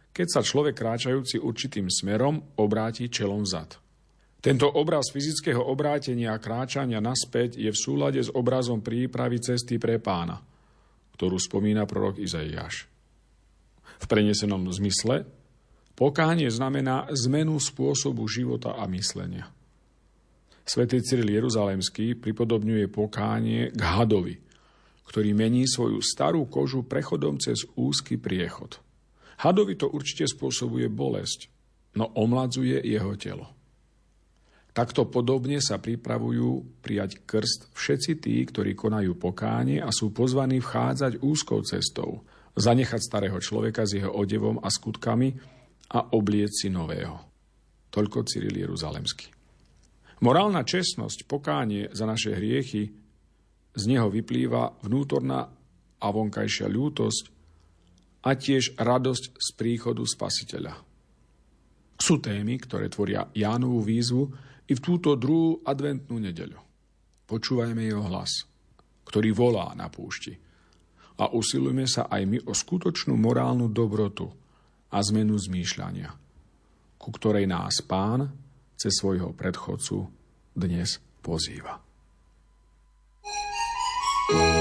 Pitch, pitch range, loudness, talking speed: 110 Hz, 95-130 Hz, -27 LUFS, 110 wpm